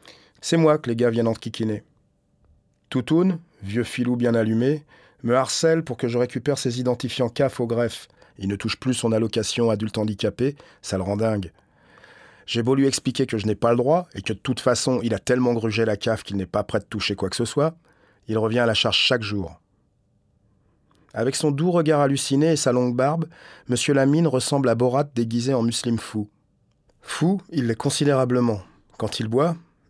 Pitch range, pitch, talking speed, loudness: 110-135 Hz, 120 Hz, 200 wpm, -23 LUFS